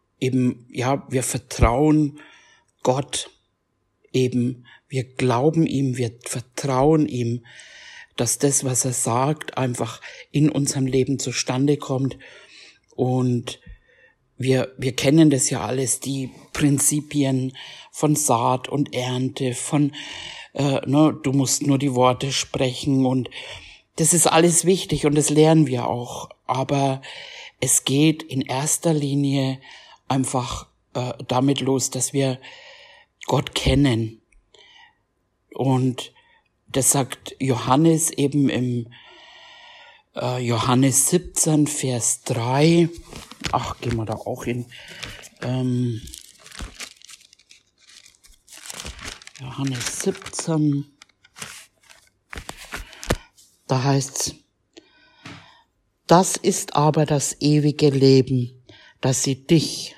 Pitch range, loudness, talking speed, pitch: 125-145 Hz, -21 LUFS, 100 wpm, 135 Hz